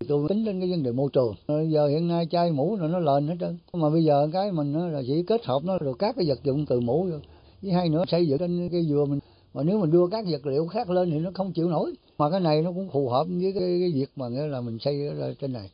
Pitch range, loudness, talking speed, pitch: 145-180 Hz, -26 LUFS, 300 wpm, 160 Hz